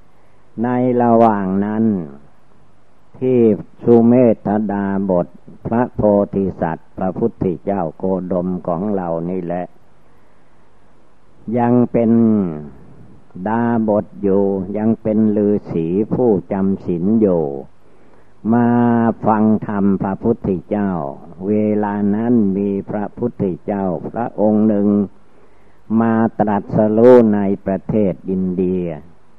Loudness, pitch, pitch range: -17 LUFS, 105 Hz, 95-115 Hz